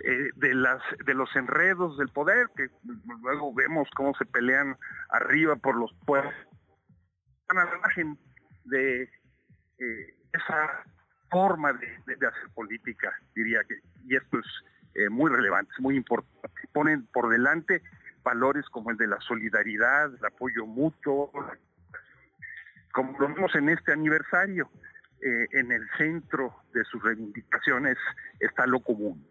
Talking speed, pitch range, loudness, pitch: 145 wpm, 120-150 Hz, -27 LUFS, 135 Hz